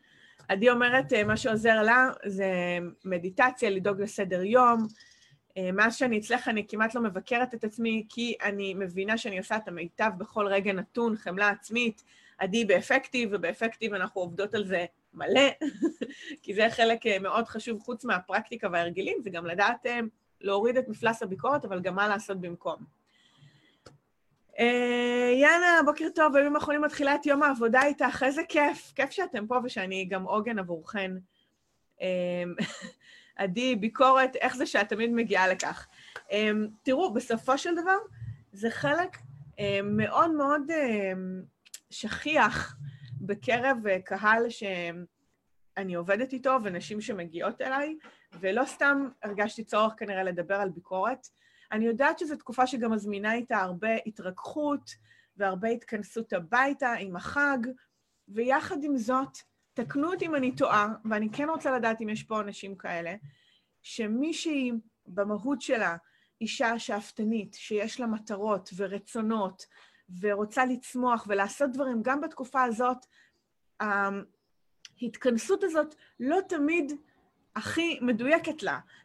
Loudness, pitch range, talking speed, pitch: -28 LUFS, 200-260 Hz, 130 wpm, 225 Hz